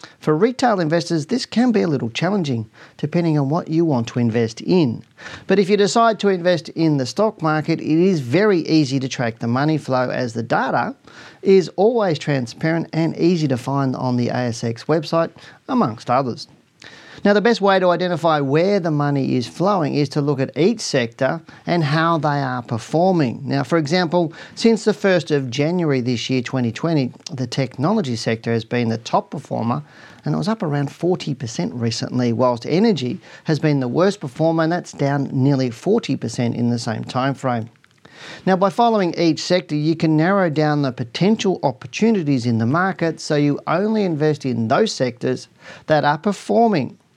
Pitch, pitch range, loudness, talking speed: 155 Hz, 130-180 Hz, -19 LUFS, 180 wpm